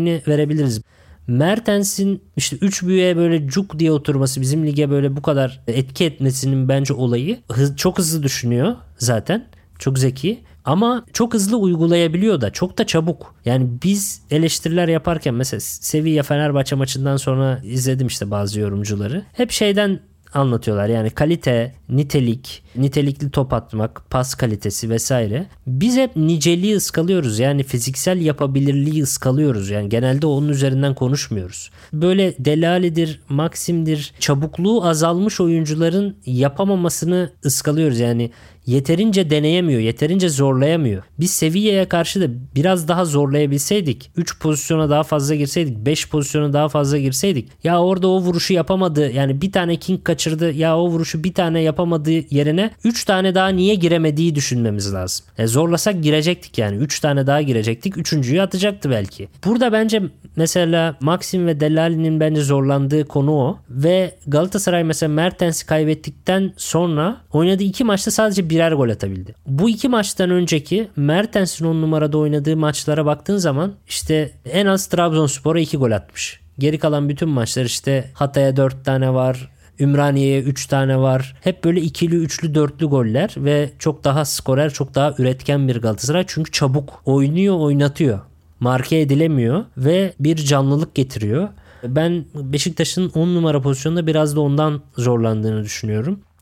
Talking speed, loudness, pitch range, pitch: 140 wpm, -18 LUFS, 135-170 Hz, 150 Hz